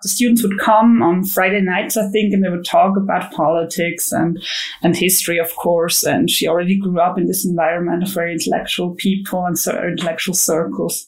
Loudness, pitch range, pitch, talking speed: -16 LUFS, 170-195 Hz, 180 Hz, 195 wpm